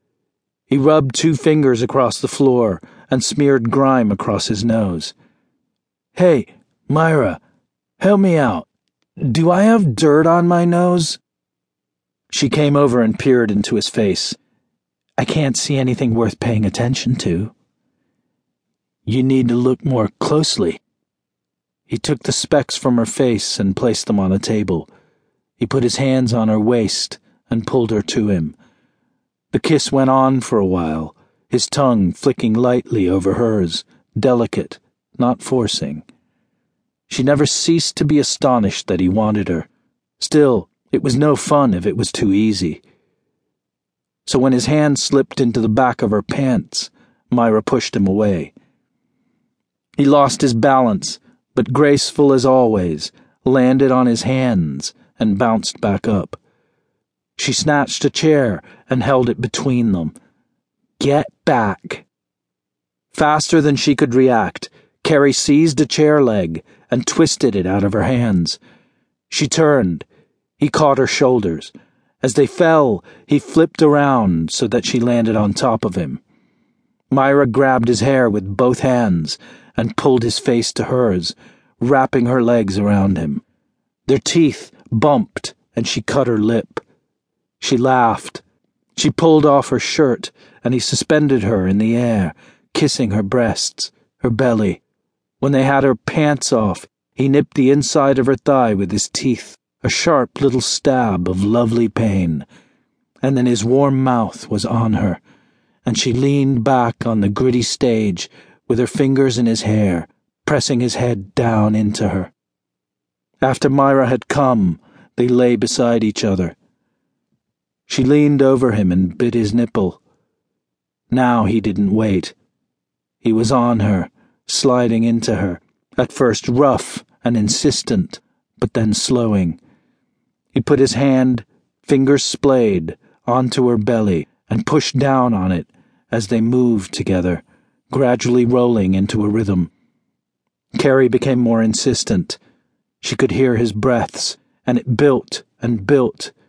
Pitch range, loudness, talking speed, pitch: 110-135 Hz, -16 LUFS, 145 wpm, 125 Hz